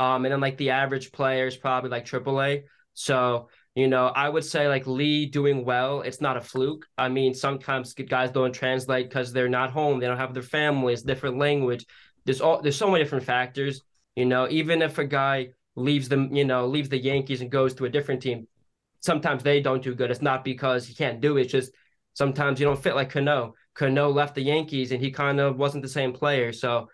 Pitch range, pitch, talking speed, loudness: 130-145 Hz, 135 Hz, 225 wpm, -25 LUFS